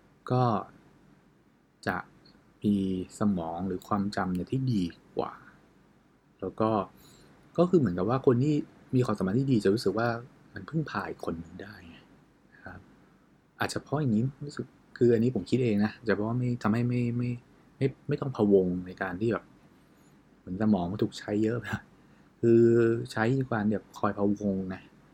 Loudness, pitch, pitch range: -29 LUFS, 110 Hz, 100-125 Hz